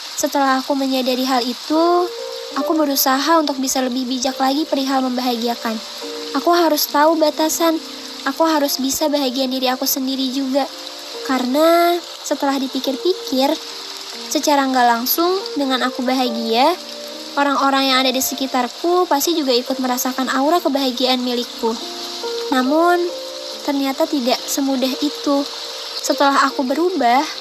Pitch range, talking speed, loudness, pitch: 260-310 Hz, 120 wpm, -18 LUFS, 275 Hz